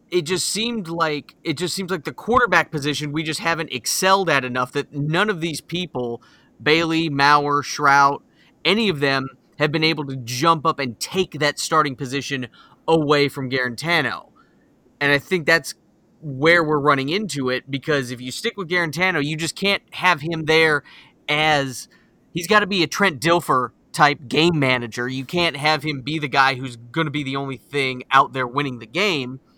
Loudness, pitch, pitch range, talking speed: -20 LUFS, 150 Hz, 135-170 Hz, 190 wpm